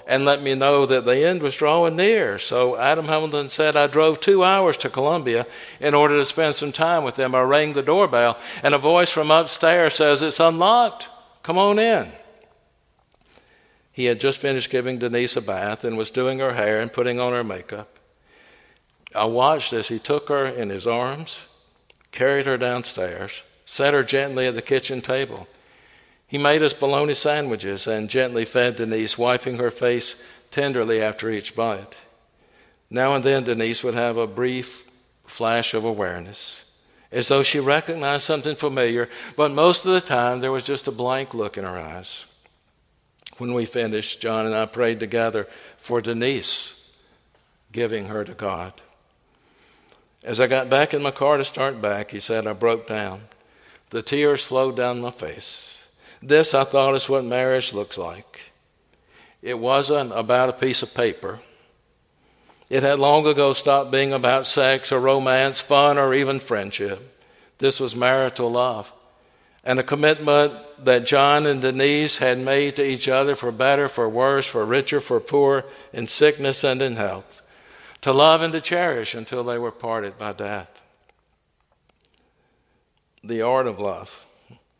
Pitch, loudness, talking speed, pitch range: 130 Hz, -20 LUFS, 165 wpm, 120-145 Hz